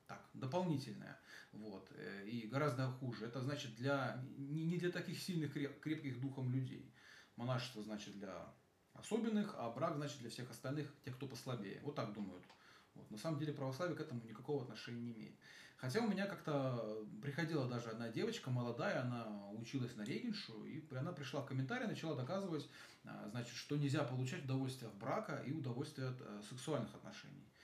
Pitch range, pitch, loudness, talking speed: 120-155 Hz, 135 Hz, -45 LUFS, 165 wpm